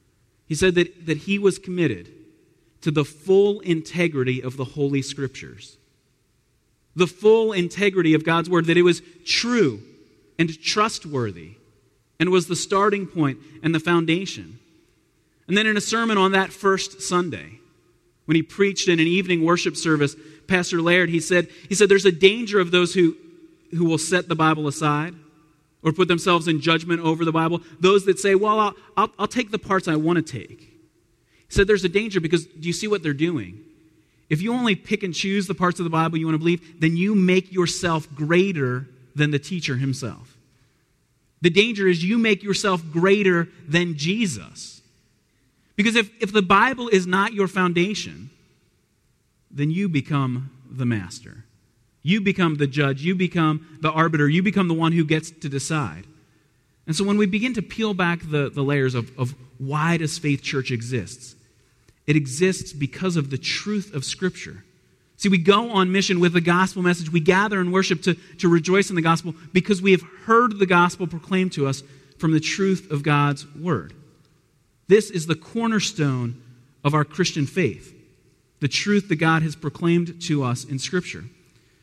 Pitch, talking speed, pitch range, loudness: 165 Hz, 180 wpm, 140-185 Hz, -21 LUFS